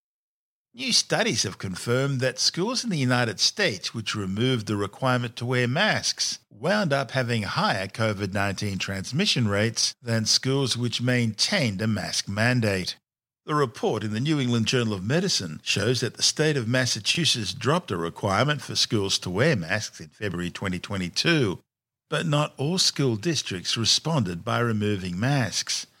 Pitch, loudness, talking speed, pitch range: 120 Hz, -24 LUFS, 150 wpm, 105-135 Hz